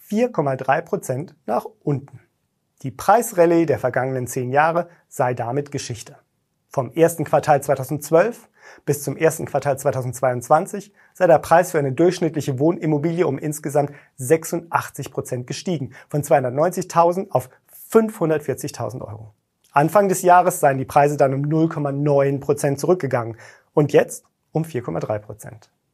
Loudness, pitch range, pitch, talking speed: -20 LUFS, 135-165 Hz, 145 Hz, 125 wpm